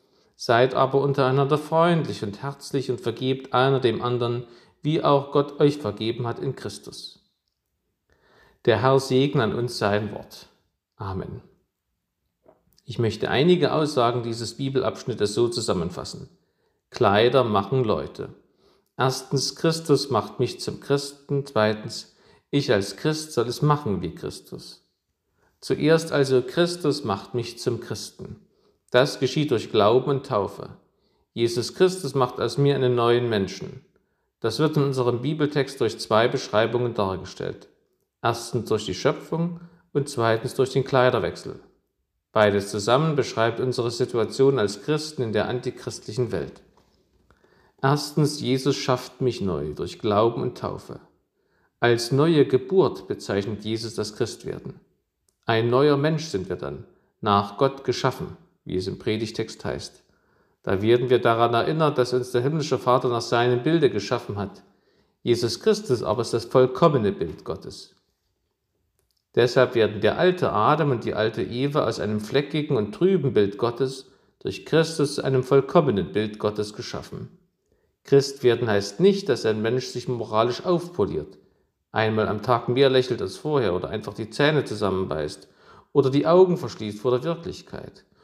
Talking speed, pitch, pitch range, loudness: 140 wpm, 125 Hz, 110-140 Hz, -23 LUFS